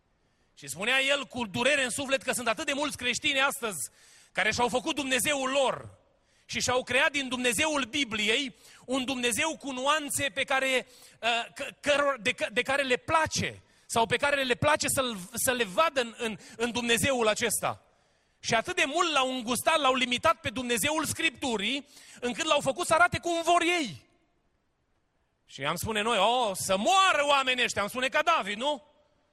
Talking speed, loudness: 165 wpm, -27 LUFS